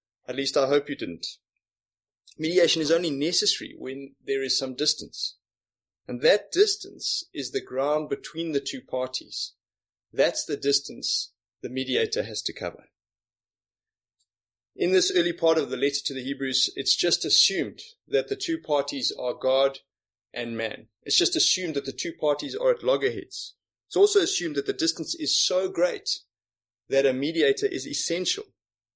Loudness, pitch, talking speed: -25 LUFS, 150 Hz, 160 wpm